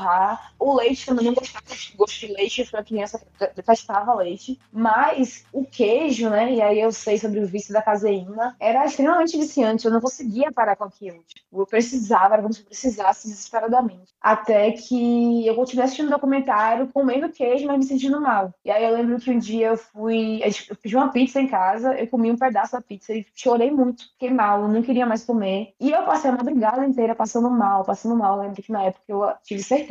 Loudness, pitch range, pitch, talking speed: -21 LUFS, 210-255 Hz, 230 Hz, 215 wpm